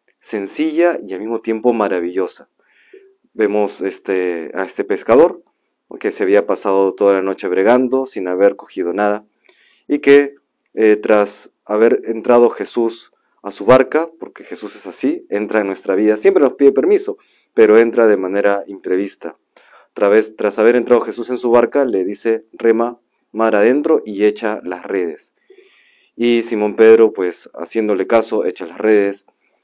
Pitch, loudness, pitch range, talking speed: 115 Hz, -15 LUFS, 105-130 Hz, 155 wpm